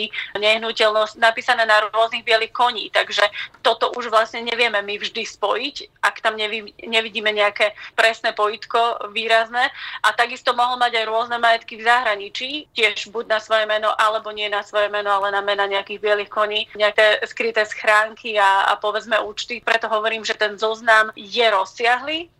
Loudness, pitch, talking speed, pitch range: -19 LUFS, 220 Hz, 165 wpm, 210-230 Hz